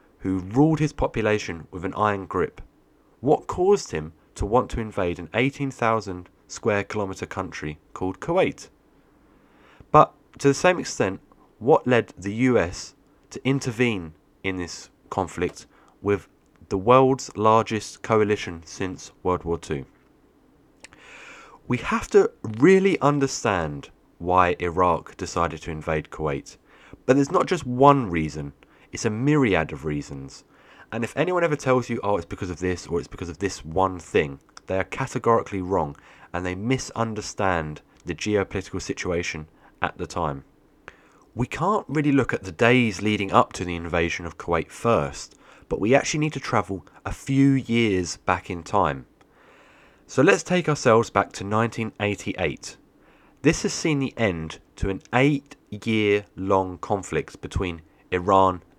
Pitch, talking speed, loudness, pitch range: 100 Hz, 150 wpm, -24 LUFS, 90-130 Hz